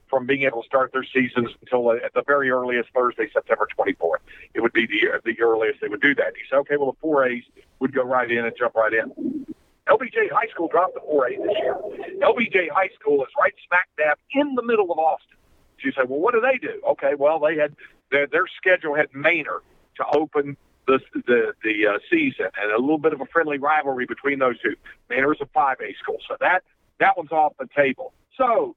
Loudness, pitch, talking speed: -22 LUFS, 155 Hz, 225 wpm